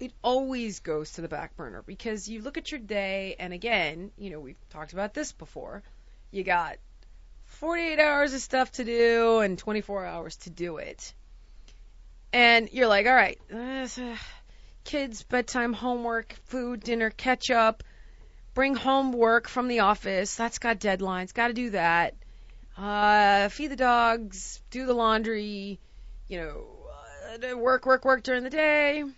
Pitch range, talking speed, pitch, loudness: 195-255 Hz, 160 wpm, 230 Hz, -26 LUFS